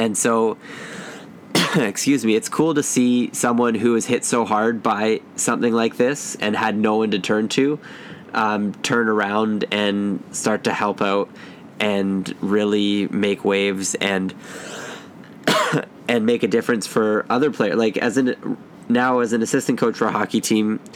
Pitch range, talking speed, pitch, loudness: 105-120 Hz, 165 wpm, 110 Hz, -20 LUFS